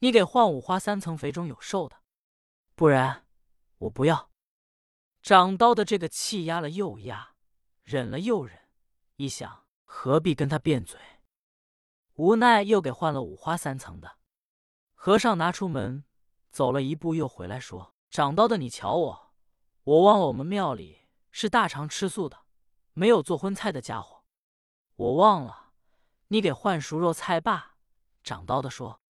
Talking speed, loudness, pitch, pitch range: 215 characters per minute, -25 LUFS, 160 Hz, 130-200 Hz